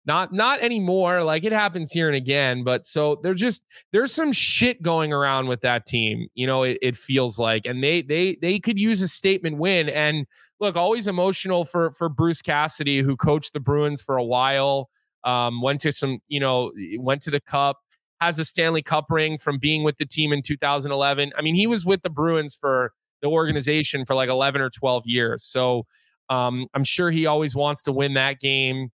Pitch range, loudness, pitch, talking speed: 135-170 Hz, -22 LUFS, 145 Hz, 205 wpm